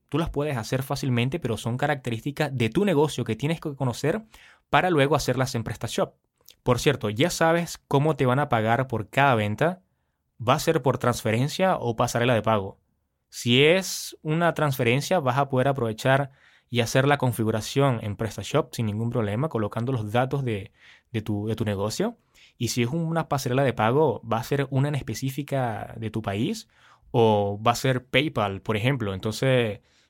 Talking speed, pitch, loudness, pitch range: 180 wpm, 125 Hz, -25 LUFS, 115-145 Hz